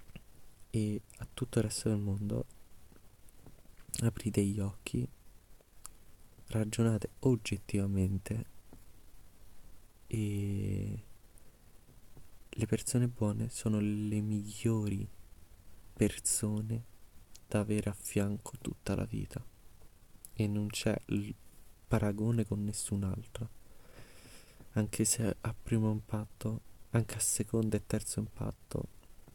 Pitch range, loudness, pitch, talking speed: 100-115 Hz, -35 LUFS, 105 Hz, 95 wpm